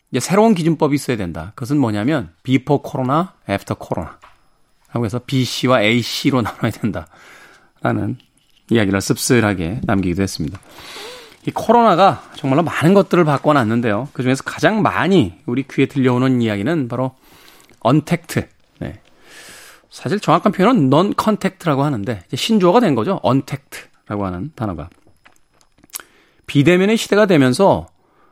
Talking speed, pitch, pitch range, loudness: 330 characters per minute, 135 Hz, 120-165 Hz, -17 LUFS